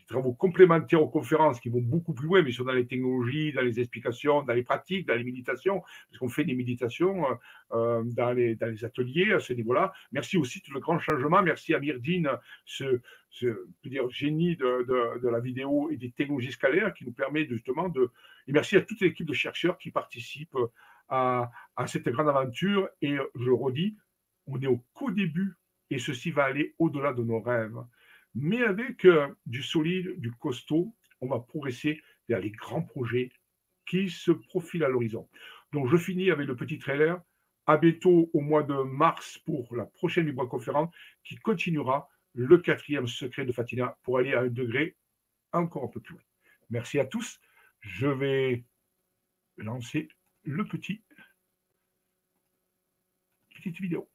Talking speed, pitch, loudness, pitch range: 175 wpm, 145 Hz, -28 LUFS, 125-175 Hz